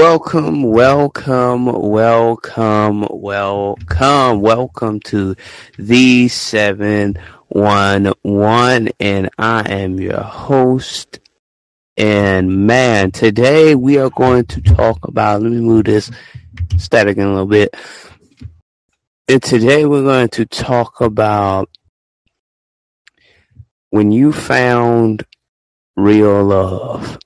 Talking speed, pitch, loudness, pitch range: 90 wpm, 105 Hz, -13 LUFS, 100-125 Hz